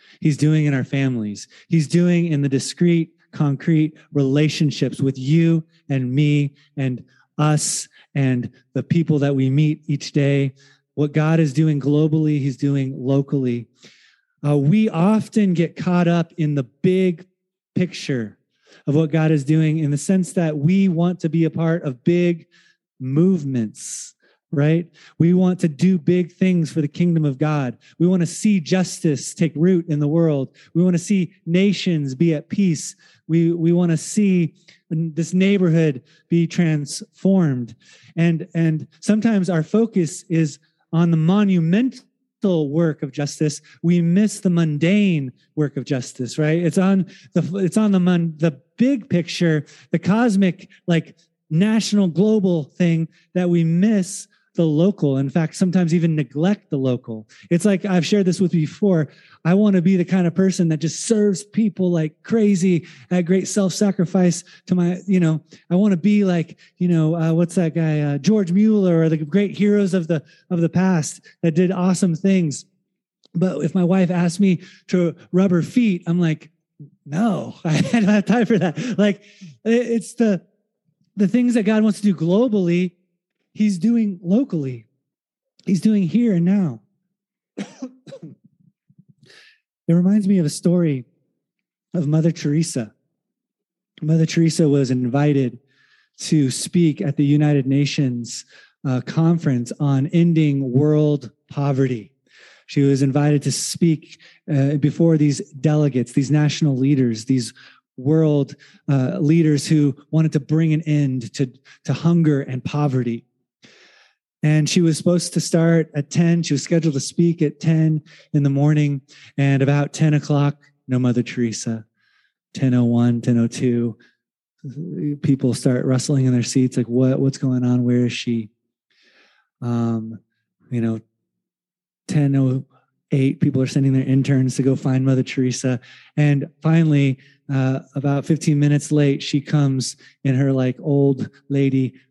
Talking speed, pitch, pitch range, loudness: 155 wpm, 160 Hz, 140-180 Hz, -19 LUFS